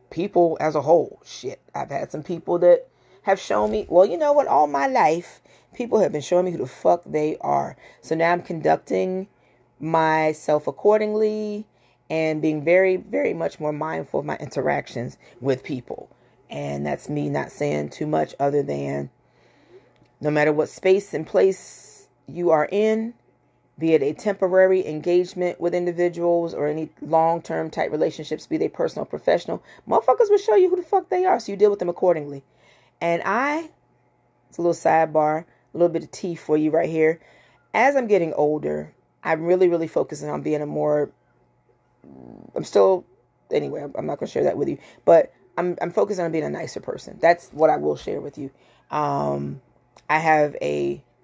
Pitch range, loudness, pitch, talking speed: 140-180 Hz, -22 LUFS, 160 Hz, 185 wpm